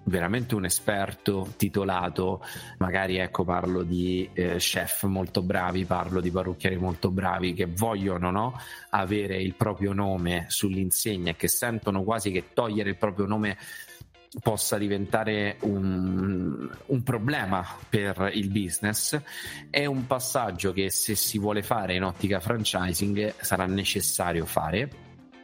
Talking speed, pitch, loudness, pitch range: 130 wpm, 95 Hz, -27 LUFS, 90-105 Hz